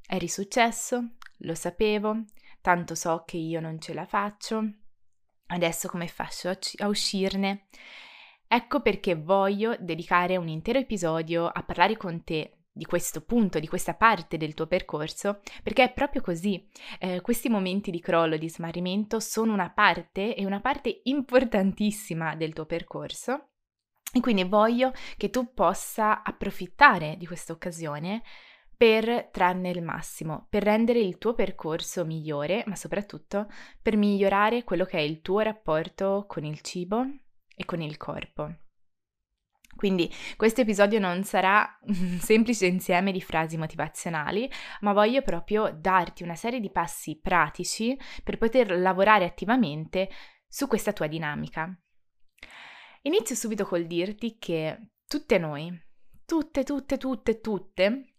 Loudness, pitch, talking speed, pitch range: -27 LUFS, 195 Hz, 140 wpm, 170-225 Hz